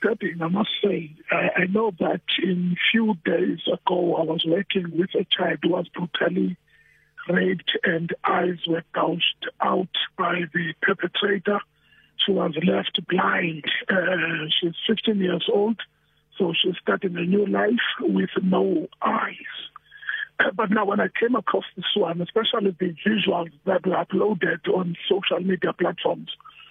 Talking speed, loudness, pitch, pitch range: 145 wpm, -23 LUFS, 180 Hz, 170-200 Hz